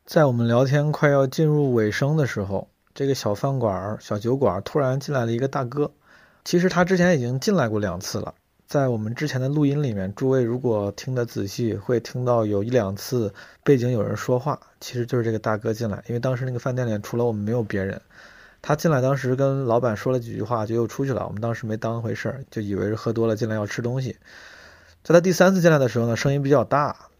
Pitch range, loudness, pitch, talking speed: 110-135 Hz, -23 LUFS, 120 Hz, 355 characters per minute